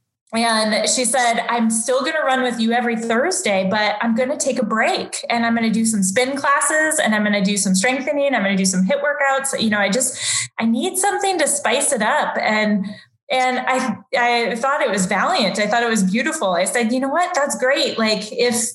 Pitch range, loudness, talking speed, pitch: 210-270 Hz, -18 LUFS, 235 wpm, 235 Hz